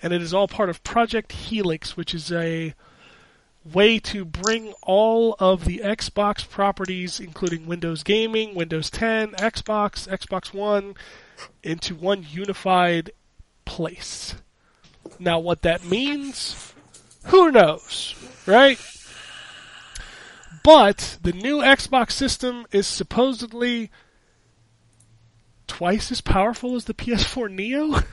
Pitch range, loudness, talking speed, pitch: 170-225 Hz, -21 LUFS, 110 wpm, 200 Hz